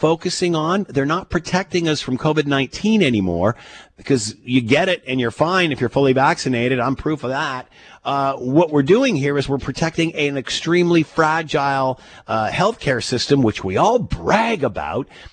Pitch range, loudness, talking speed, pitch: 130-165 Hz, -18 LUFS, 170 wpm, 140 Hz